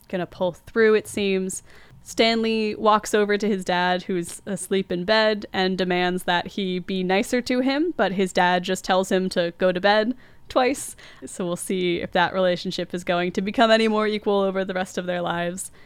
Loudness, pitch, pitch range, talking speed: -22 LUFS, 190 Hz, 180-215 Hz, 205 wpm